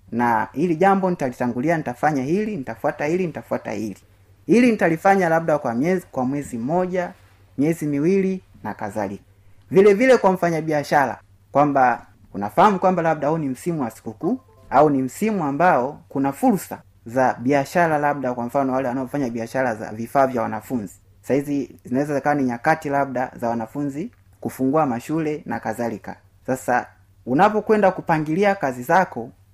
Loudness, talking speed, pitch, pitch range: -21 LUFS, 150 wpm, 140 Hz, 115-165 Hz